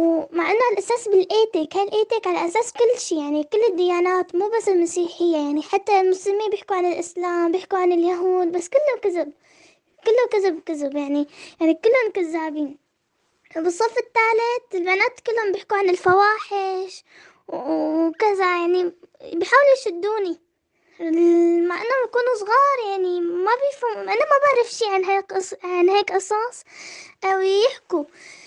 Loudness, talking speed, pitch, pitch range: -20 LUFS, 140 wpm, 375 Hz, 340-430 Hz